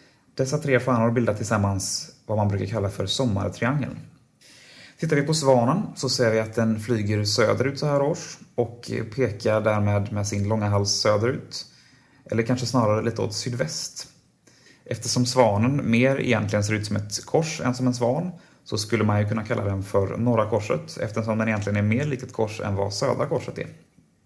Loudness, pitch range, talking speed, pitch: -24 LUFS, 105-130 Hz, 185 wpm, 115 Hz